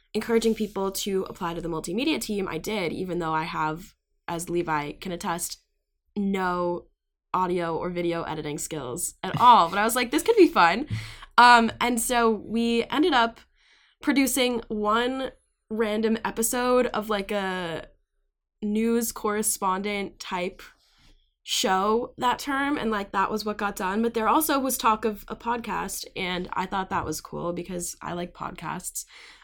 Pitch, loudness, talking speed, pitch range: 210 Hz, -25 LUFS, 160 wpm, 175-230 Hz